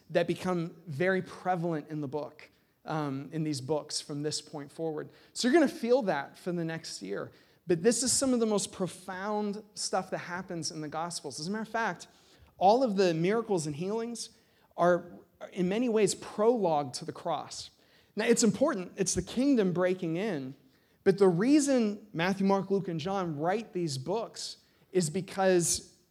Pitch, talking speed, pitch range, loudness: 185 Hz, 180 wpm, 165-210 Hz, -30 LUFS